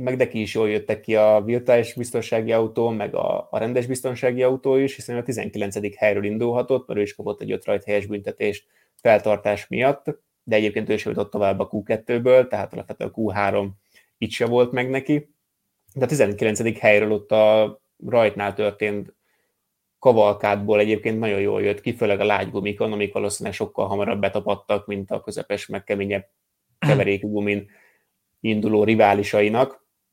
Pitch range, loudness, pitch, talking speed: 100-120 Hz, -22 LUFS, 105 Hz, 160 wpm